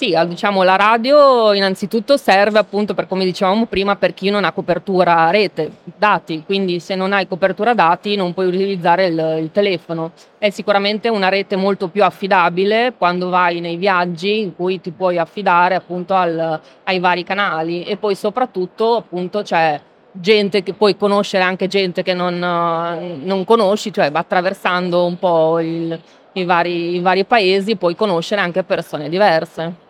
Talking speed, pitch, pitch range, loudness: 165 wpm, 185 Hz, 175-205 Hz, -16 LUFS